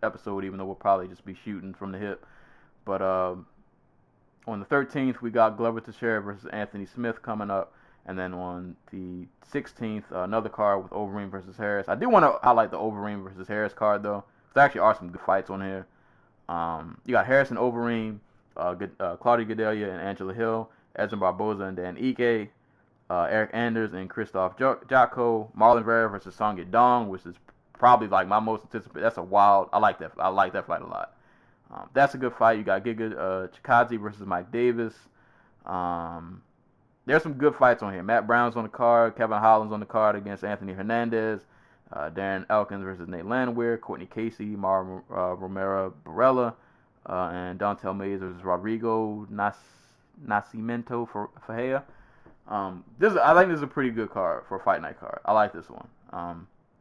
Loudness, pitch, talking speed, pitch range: -26 LUFS, 105 Hz, 190 wpm, 95-115 Hz